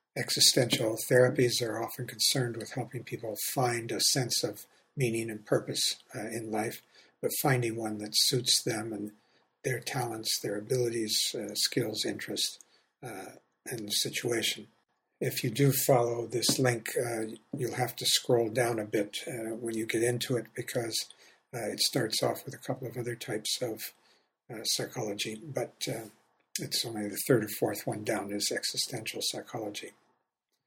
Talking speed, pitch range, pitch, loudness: 160 wpm, 115-125 Hz, 120 Hz, -30 LUFS